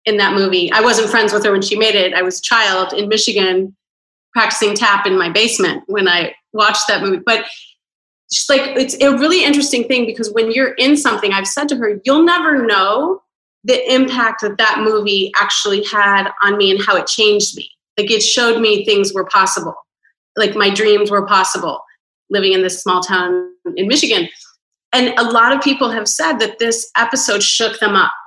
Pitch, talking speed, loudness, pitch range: 215 Hz, 195 wpm, -13 LUFS, 200-250 Hz